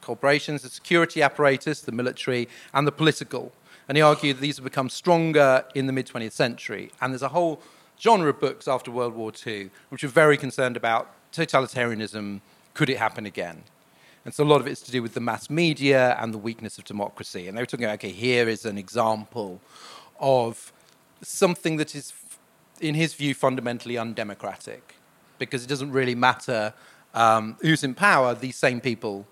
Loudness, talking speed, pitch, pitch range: -24 LUFS, 185 wpm, 130 Hz, 115-145 Hz